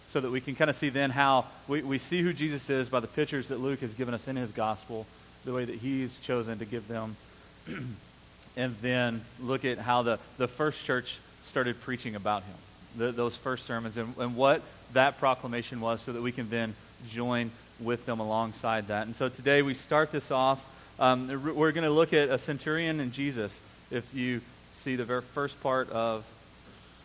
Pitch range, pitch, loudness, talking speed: 115-135 Hz, 125 Hz, -31 LUFS, 205 wpm